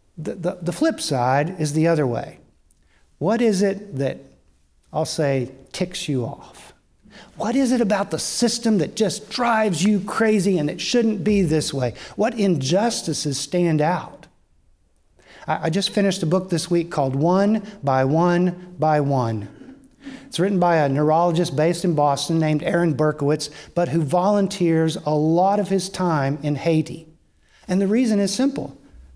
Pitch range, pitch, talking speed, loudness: 150-200 Hz, 170 Hz, 165 wpm, -21 LUFS